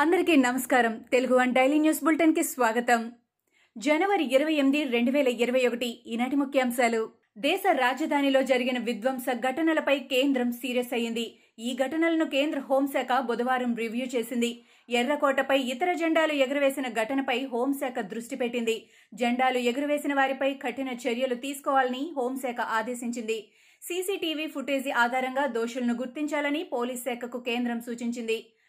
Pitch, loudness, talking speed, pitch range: 260 Hz, -27 LUFS, 100 wpm, 240-280 Hz